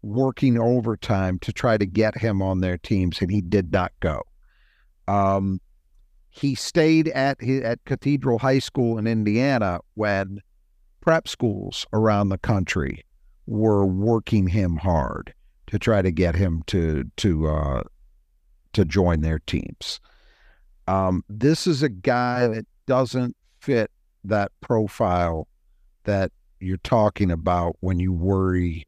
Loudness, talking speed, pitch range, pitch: -23 LUFS, 135 wpm, 90-115 Hz, 100 Hz